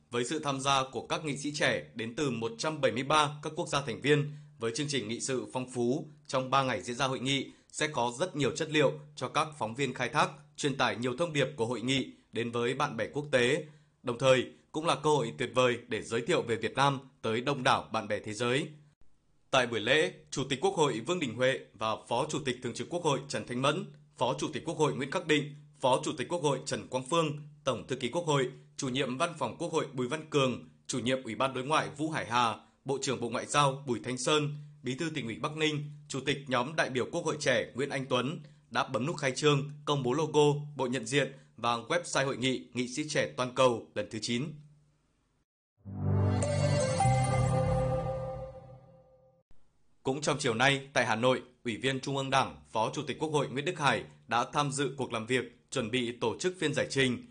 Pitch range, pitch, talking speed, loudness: 125-150 Hz, 135 Hz, 230 wpm, -31 LUFS